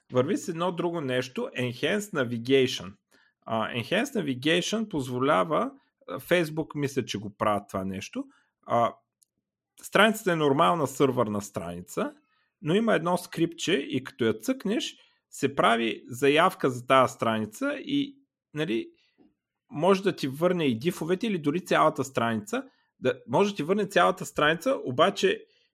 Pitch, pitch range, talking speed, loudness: 155 Hz, 125-205 Hz, 135 wpm, -27 LUFS